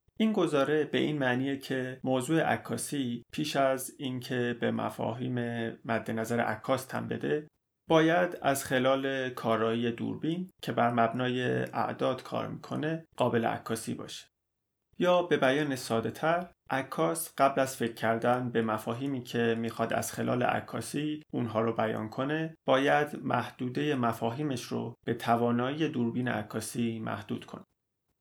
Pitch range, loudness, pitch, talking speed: 115-145 Hz, -31 LUFS, 125 Hz, 130 wpm